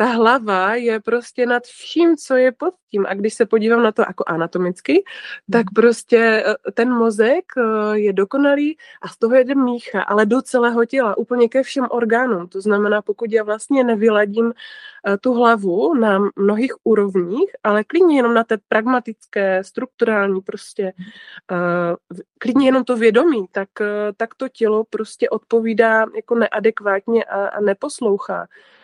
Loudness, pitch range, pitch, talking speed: -17 LUFS, 210-245 Hz, 225 Hz, 150 wpm